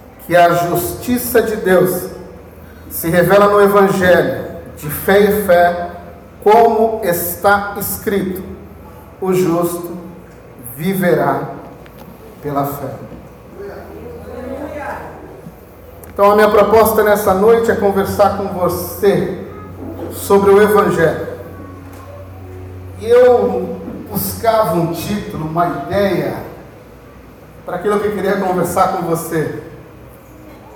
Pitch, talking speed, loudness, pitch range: 180 Hz, 95 wpm, -14 LUFS, 155-205 Hz